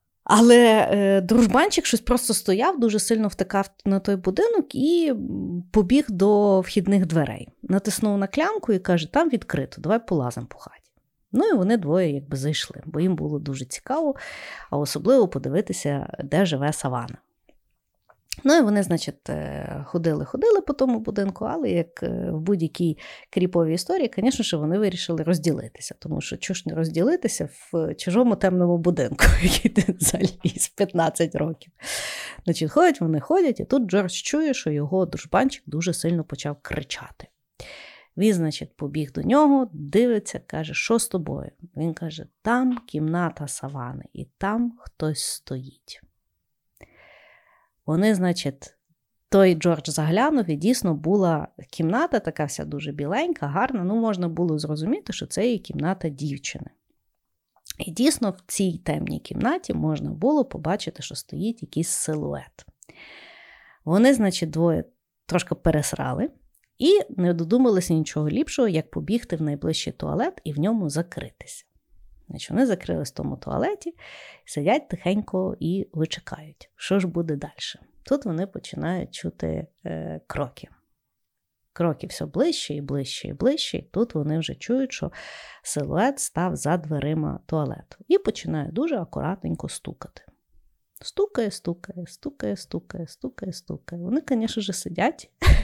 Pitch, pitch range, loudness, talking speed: 180 Hz, 155-220 Hz, -24 LUFS, 135 wpm